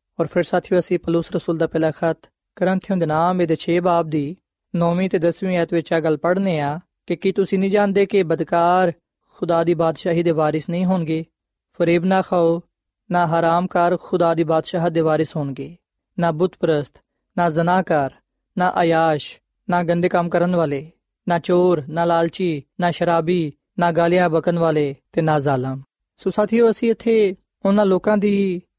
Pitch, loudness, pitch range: 170 Hz, -19 LUFS, 165-180 Hz